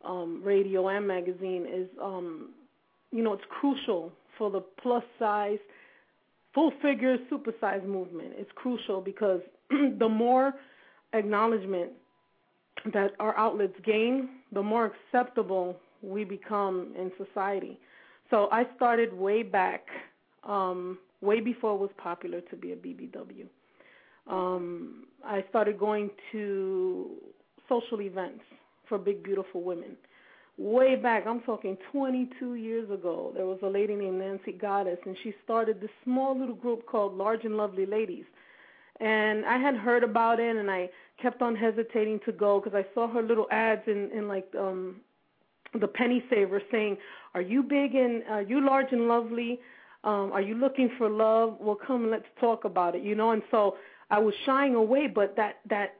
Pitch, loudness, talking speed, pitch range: 215 Hz, -29 LUFS, 160 wpm, 195-240 Hz